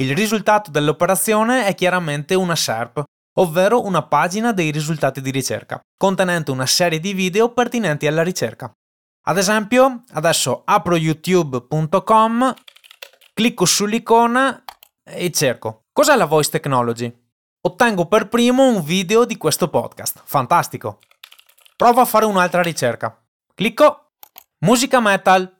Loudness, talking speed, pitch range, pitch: -17 LUFS, 120 wpm, 150-225 Hz, 185 Hz